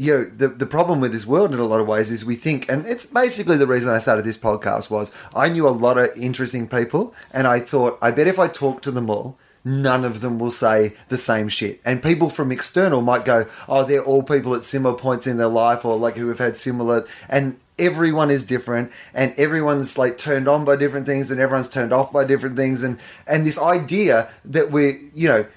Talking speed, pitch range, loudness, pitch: 235 wpm, 120-140 Hz, -19 LUFS, 130 Hz